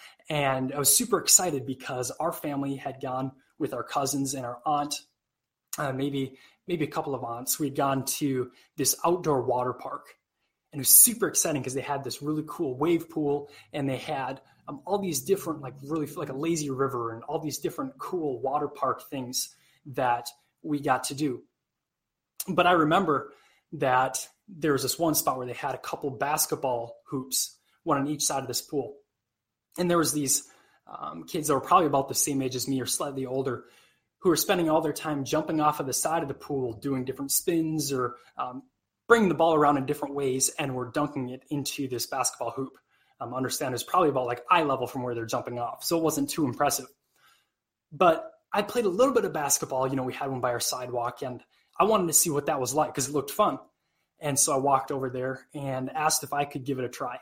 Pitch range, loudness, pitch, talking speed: 130-155 Hz, -27 LUFS, 140 Hz, 215 wpm